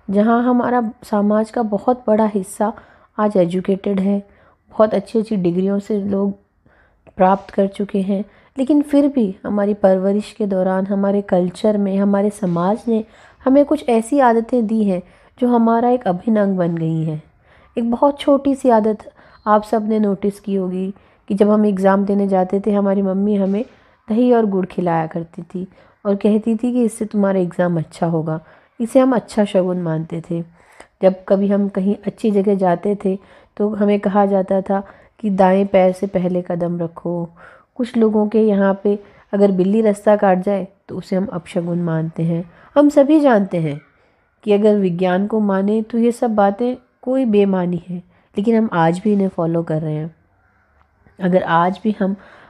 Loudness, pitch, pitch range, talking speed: -17 LUFS, 200 Hz, 185-220 Hz, 175 wpm